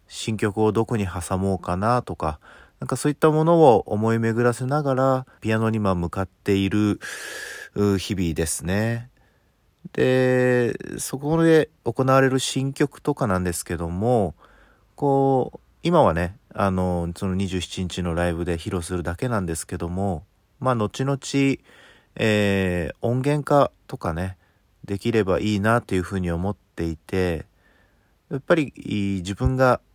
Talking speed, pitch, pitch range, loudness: 265 characters per minute, 105 Hz, 90-130 Hz, -23 LUFS